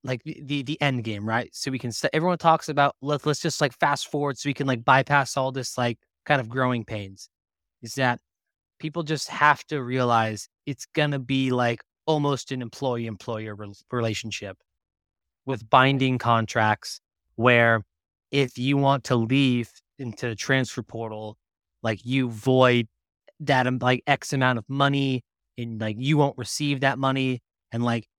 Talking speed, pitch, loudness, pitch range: 165 wpm, 125 Hz, -24 LUFS, 115-140 Hz